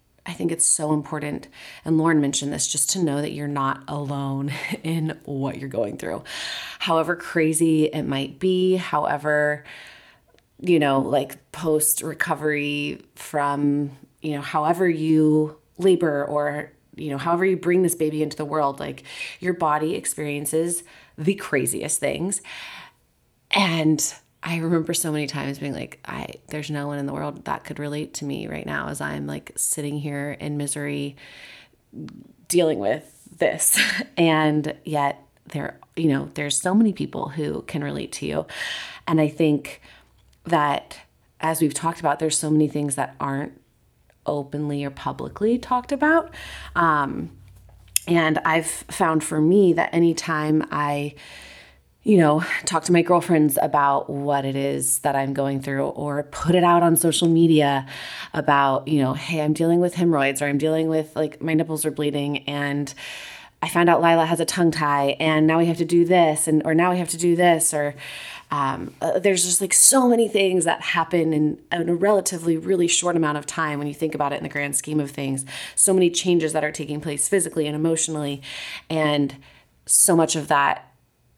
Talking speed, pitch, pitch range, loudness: 175 wpm, 155 Hz, 145-170 Hz, -22 LUFS